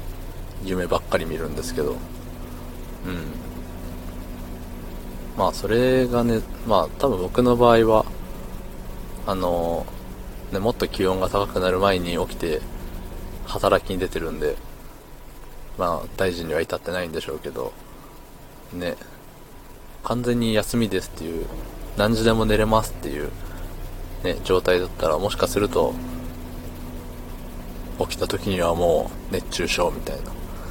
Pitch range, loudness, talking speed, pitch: 85-100 Hz, -23 LUFS, 250 characters per minute, 90 Hz